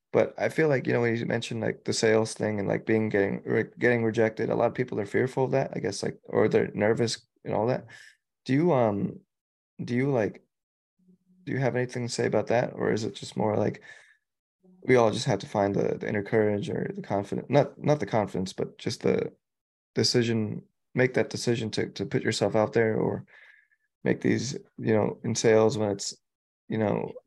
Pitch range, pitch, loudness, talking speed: 110-140 Hz, 115 Hz, -27 LUFS, 215 wpm